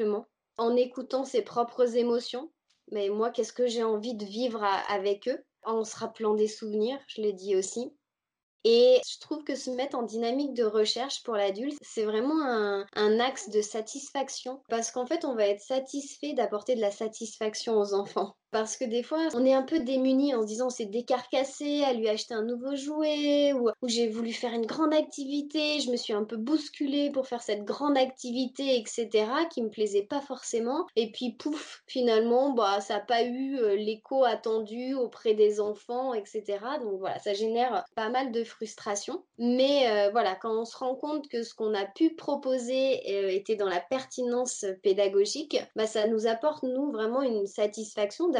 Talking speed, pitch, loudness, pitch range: 190 wpm, 240 Hz, -29 LUFS, 220-265 Hz